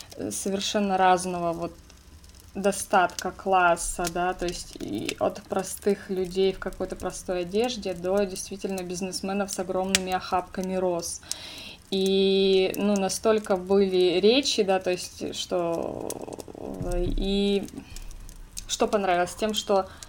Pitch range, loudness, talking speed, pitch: 180-200 Hz, -26 LUFS, 110 wpm, 190 Hz